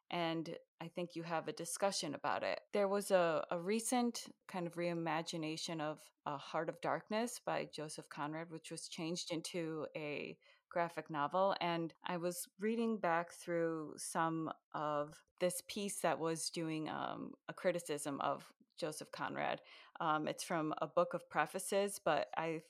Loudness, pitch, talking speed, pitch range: -40 LUFS, 170 Hz, 160 wpm, 160-185 Hz